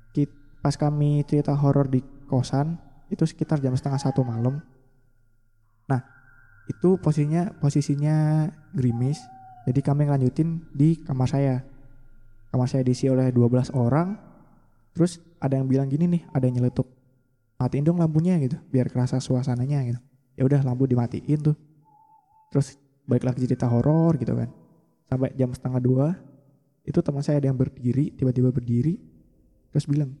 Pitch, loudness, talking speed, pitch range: 135 Hz, -24 LUFS, 145 wpm, 125-150 Hz